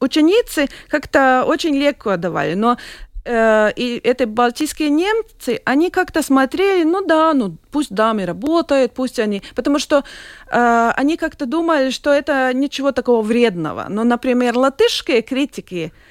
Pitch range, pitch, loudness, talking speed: 235-305 Hz, 265 Hz, -17 LUFS, 140 wpm